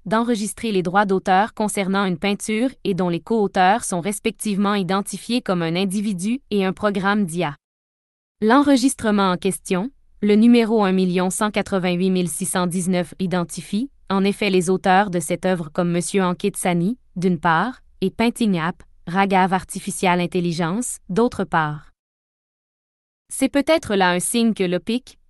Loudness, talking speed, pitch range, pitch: -20 LUFS, 135 wpm, 180-215 Hz, 195 Hz